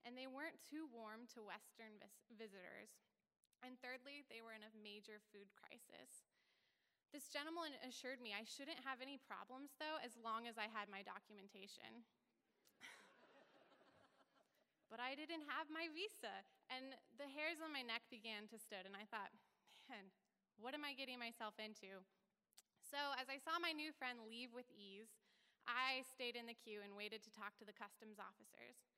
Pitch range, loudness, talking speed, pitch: 210-275 Hz, -52 LUFS, 170 wpm, 235 Hz